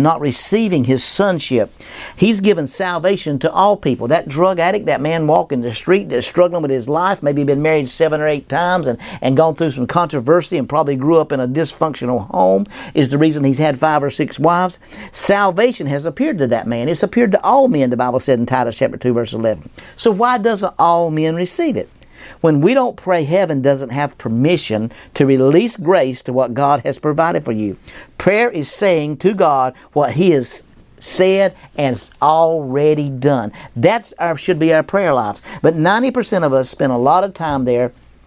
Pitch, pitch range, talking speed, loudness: 155 Hz, 135-180 Hz, 200 wpm, -16 LUFS